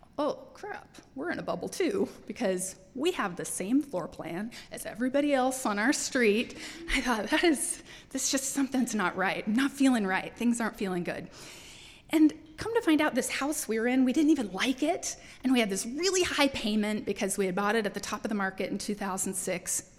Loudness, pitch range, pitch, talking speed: -29 LUFS, 200-280 Hz, 240 Hz, 215 wpm